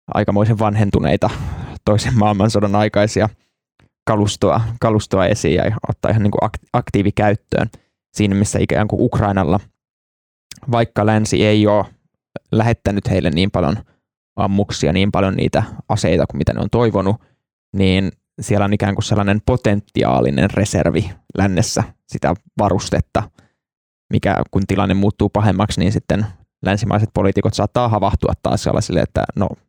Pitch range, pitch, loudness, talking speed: 95-110 Hz, 105 Hz, -17 LUFS, 125 wpm